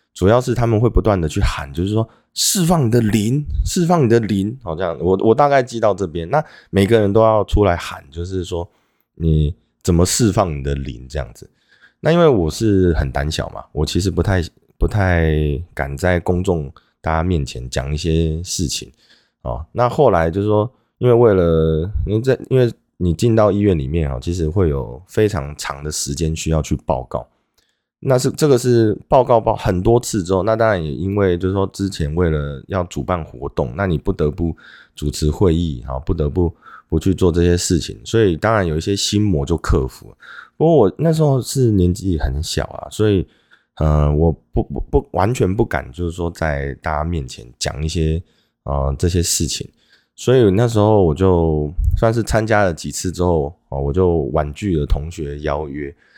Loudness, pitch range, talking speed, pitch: -18 LUFS, 75-105 Hz, 270 characters per minute, 85 Hz